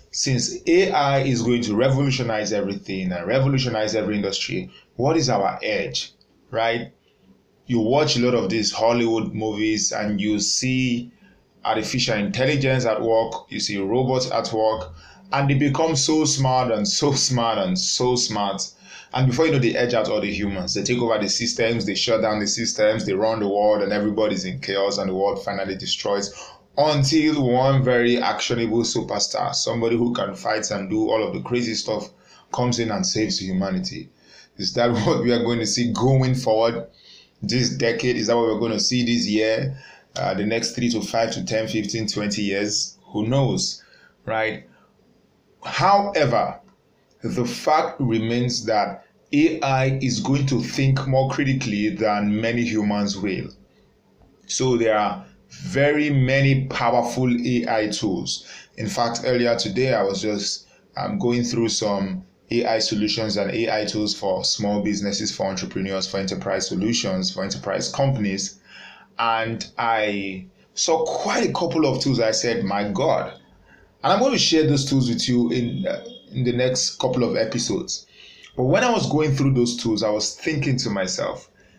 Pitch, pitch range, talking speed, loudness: 115 Hz, 105-130 Hz, 170 wpm, -22 LUFS